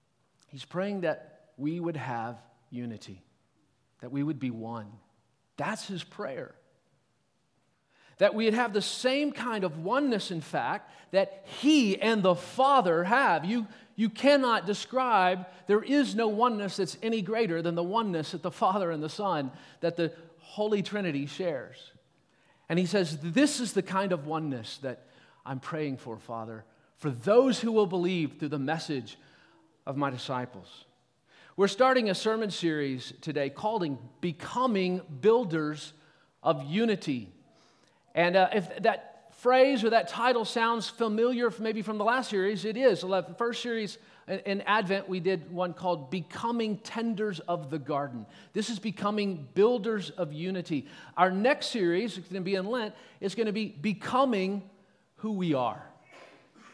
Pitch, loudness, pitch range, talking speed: 185 Hz, -29 LUFS, 155-220 Hz, 155 wpm